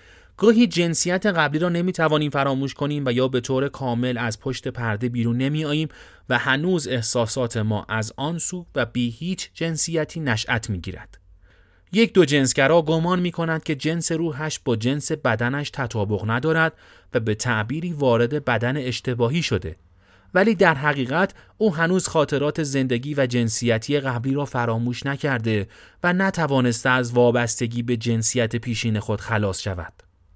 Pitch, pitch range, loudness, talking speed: 130 Hz, 120-160 Hz, -22 LUFS, 150 wpm